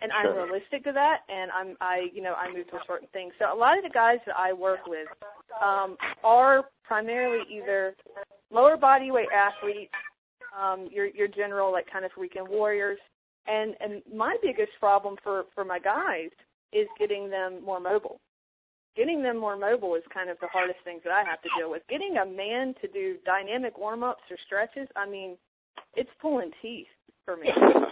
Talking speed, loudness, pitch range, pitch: 195 wpm, -27 LUFS, 185-245 Hz, 200 Hz